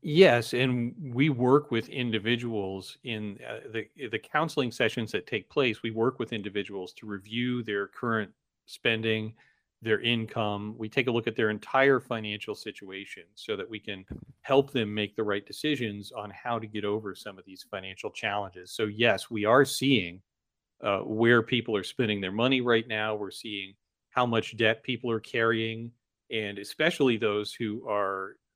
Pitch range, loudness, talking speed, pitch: 105-120 Hz, -28 LUFS, 170 wpm, 110 Hz